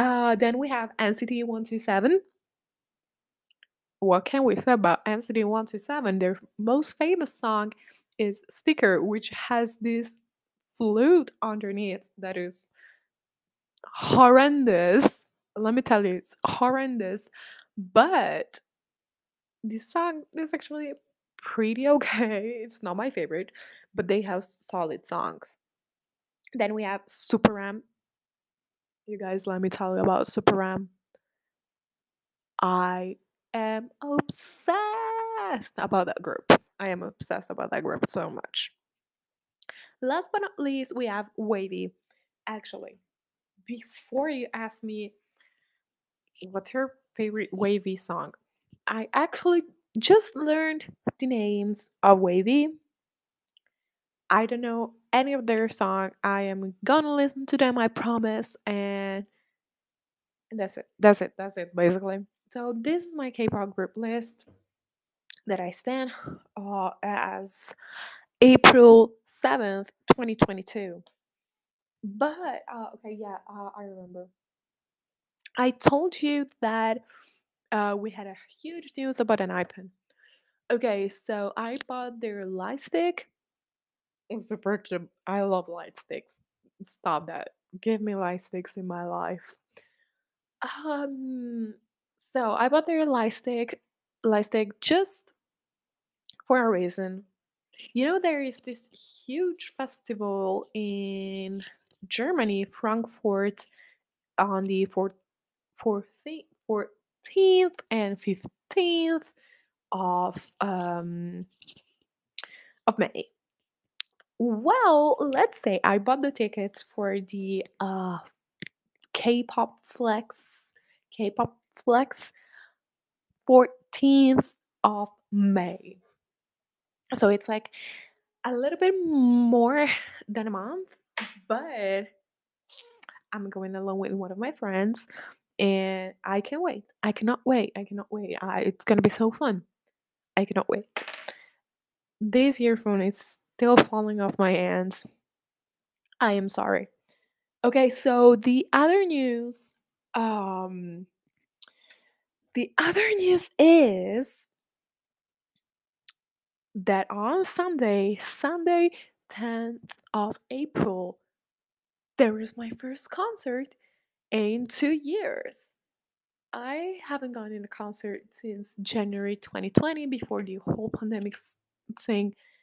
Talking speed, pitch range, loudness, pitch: 115 wpm, 200-265 Hz, -25 LUFS, 225 Hz